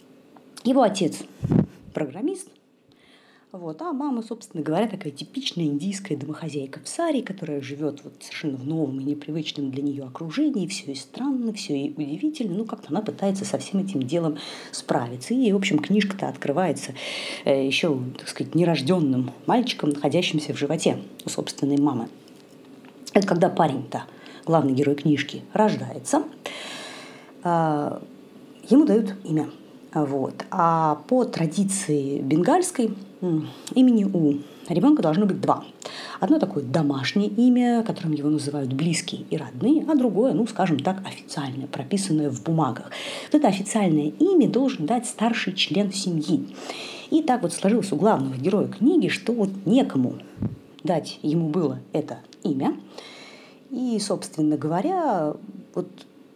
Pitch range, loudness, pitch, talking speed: 150-230 Hz, -24 LUFS, 175 Hz, 135 wpm